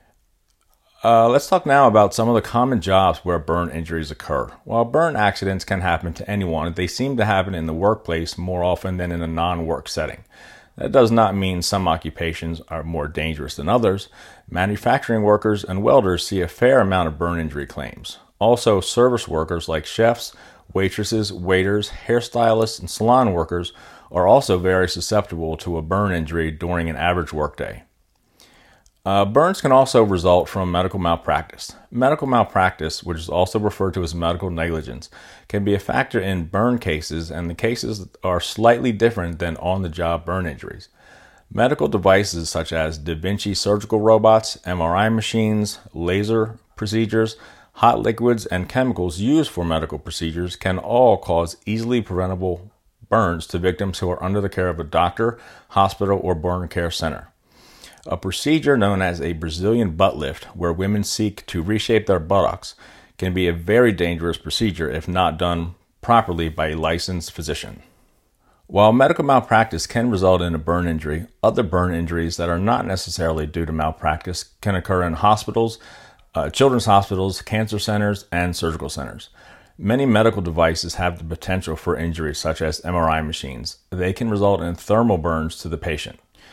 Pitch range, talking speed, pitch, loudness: 85-105 Hz, 165 wpm, 90 Hz, -20 LUFS